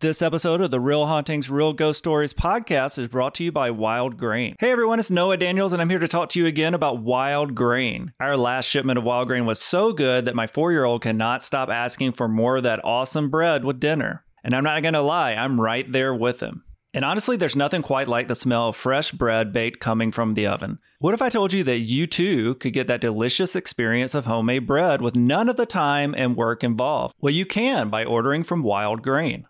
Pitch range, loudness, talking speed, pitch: 120-160 Hz, -22 LUFS, 235 wpm, 135 Hz